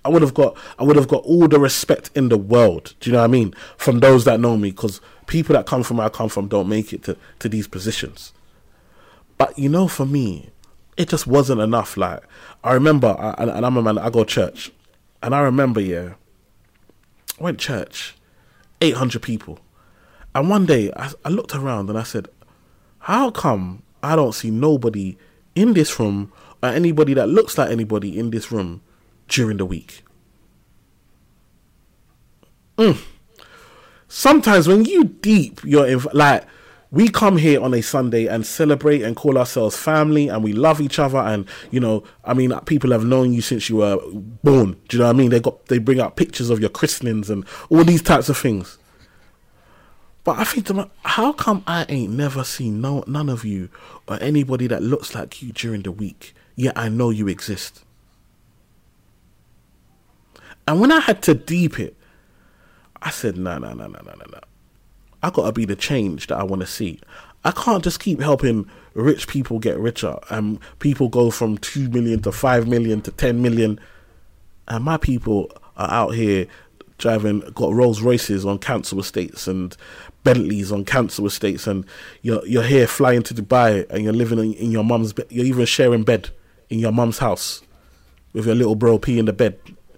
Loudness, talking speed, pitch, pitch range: -18 LUFS, 190 wpm, 115 Hz, 105-140 Hz